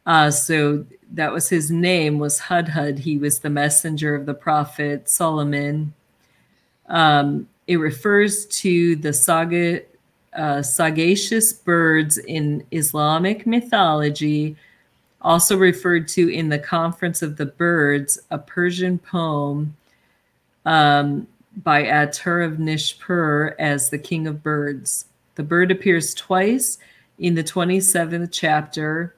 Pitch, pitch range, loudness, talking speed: 160 Hz, 150-175 Hz, -19 LUFS, 120 wpm